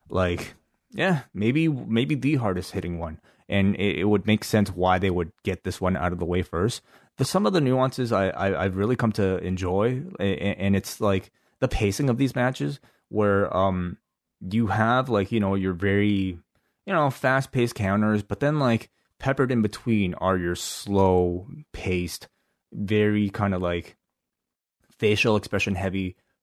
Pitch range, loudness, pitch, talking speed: 95-120 Hz, -25 LUFS, 100 Hz, 175 wpm